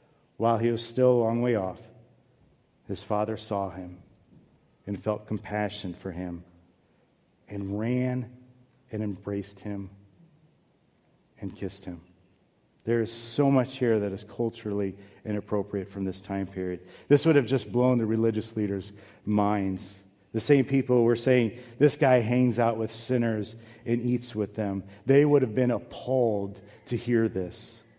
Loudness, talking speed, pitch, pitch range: -27 LUFS, 150 wpm, 110 Hz, 100-125 Hz